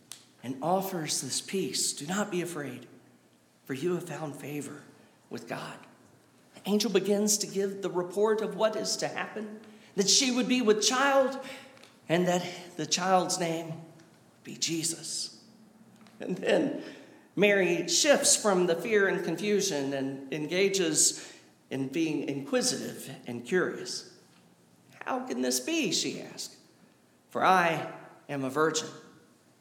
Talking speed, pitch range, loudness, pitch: 140 wpm, 145-210 Hz, -28 LUFS, 180 Hz